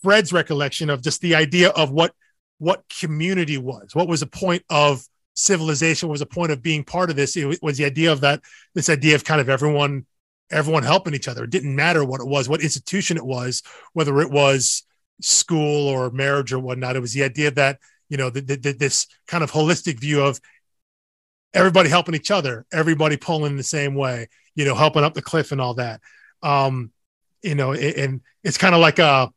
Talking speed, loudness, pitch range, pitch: 215 wpm, -20 LUFS, 135-165 Hz, 150 Hz